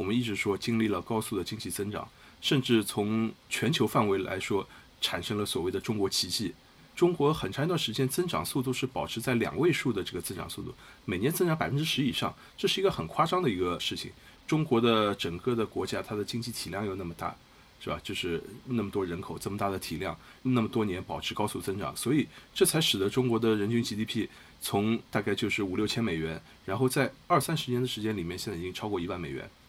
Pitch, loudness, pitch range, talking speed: 110 Hz, -30 LUFS, 100-130 Hz, 345 characters per minute